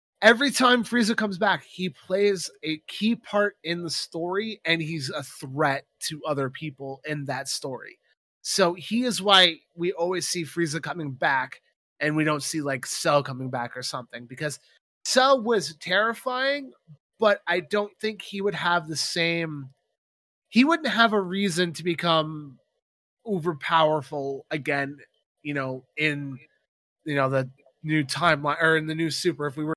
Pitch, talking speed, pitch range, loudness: 160 Hz, 165 wpm, 145-195 Hz, -25 LUFS